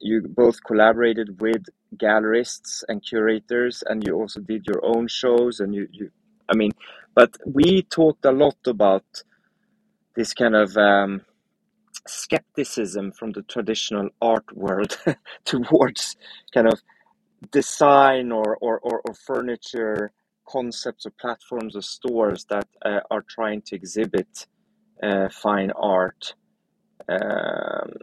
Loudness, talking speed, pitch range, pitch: -22 LUFS, 125 wpm, 105-125 Hz, 115 Hz